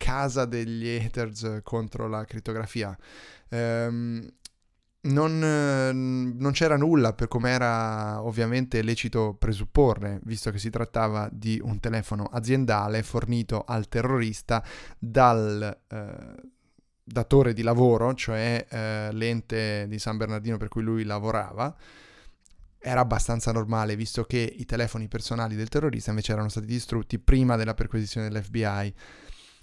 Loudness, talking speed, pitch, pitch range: -27 LUFS, 125 wpm, 115 Hz, 110-120 Hz